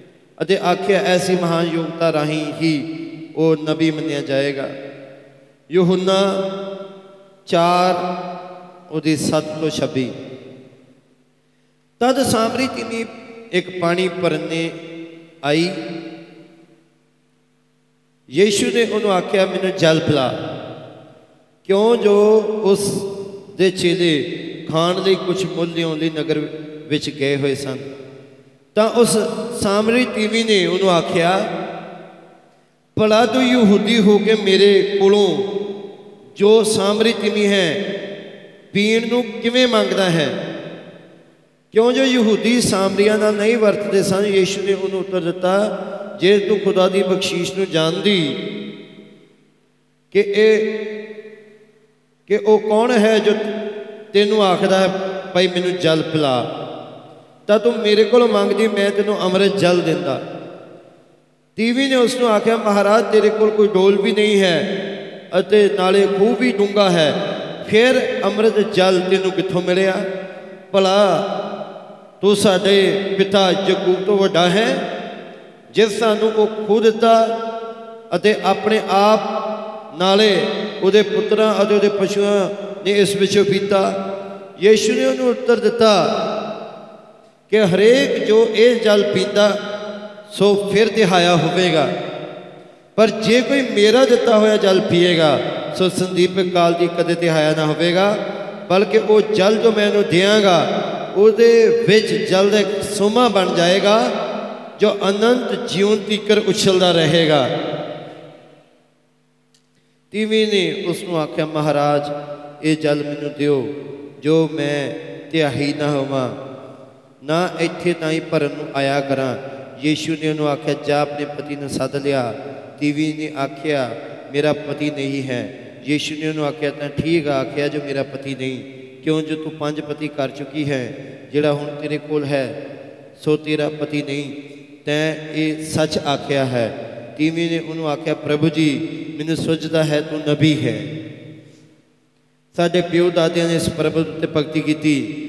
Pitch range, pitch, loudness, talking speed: 155-210 Hz, 185 Hz, -17 LUFS, 125 wpm